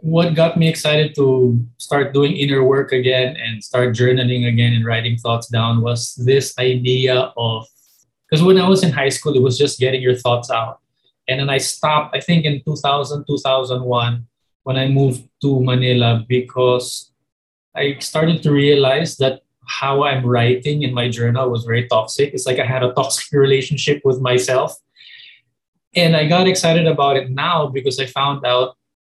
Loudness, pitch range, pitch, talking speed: -16 LUFS, 125-145 Hz, 130 Hz, 175 wpm